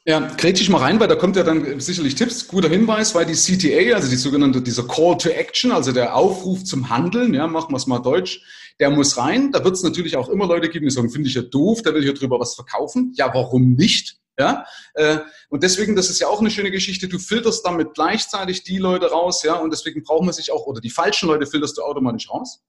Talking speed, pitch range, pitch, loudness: 245 wpm, 140-190 Hz, 165 Hz, -18 LUFS